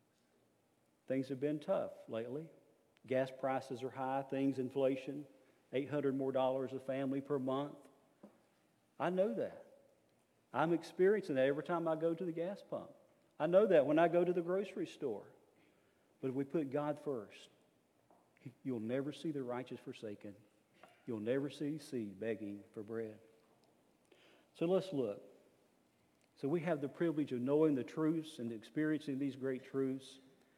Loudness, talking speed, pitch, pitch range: -38 LUFS, 155 wpm, 135 Hz, 125-155 Hz